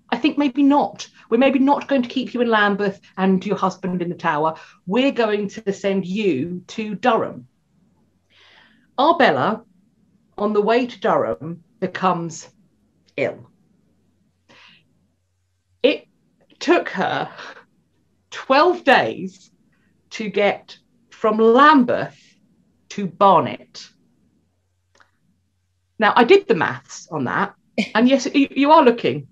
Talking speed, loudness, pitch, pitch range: 120 wpm, -18 LUFS, 205 Hz, 175-245 Hz